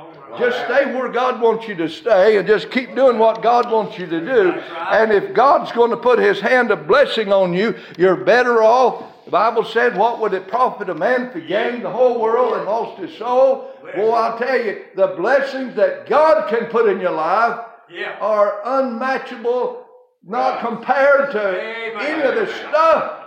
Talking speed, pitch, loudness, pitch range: 190 wpm, 235 Hz, -17 LUFS, 215-265 Hz